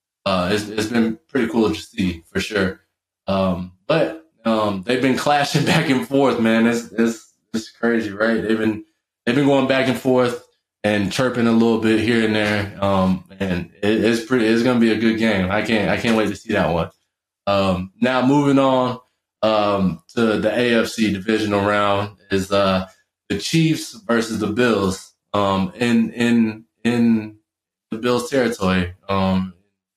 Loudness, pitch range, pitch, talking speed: -19 LUFS, 100-120 Hz, 110 Hz, 170 wpm